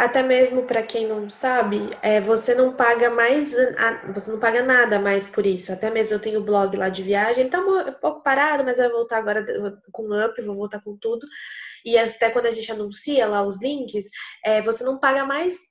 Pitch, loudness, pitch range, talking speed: 230 Hz, -21 LUFS, 210-255 Hz, 220 wpm